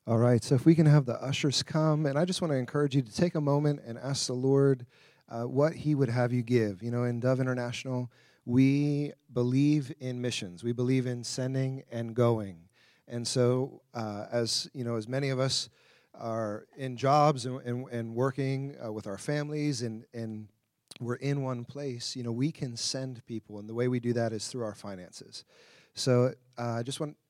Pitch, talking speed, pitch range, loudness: 125 Hz, 210 wpm, 120-140 Hz, -30 LUFS